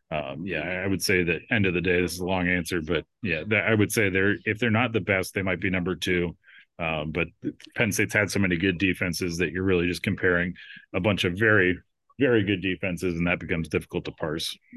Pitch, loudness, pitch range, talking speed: 95 Hz, -25 LUFS, 90-100 Hz, 235 wpm